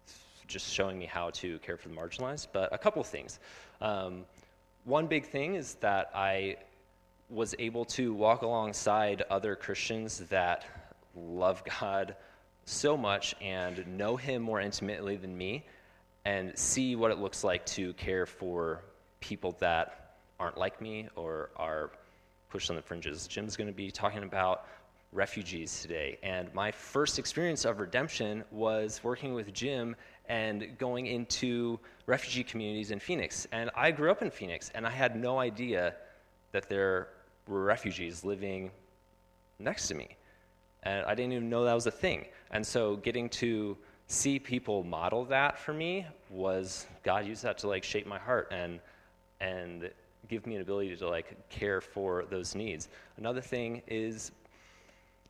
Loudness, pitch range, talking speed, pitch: -34 LUFS, 95-120 Hz, 160 wpm, 105 Hz